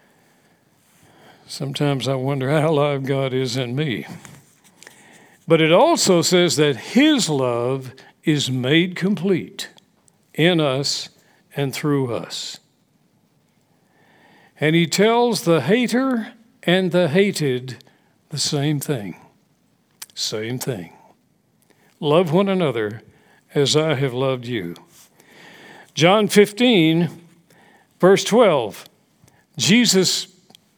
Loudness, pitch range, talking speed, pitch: -19 LUFS, 140-190 Hz, 95 wpm, 160 Hz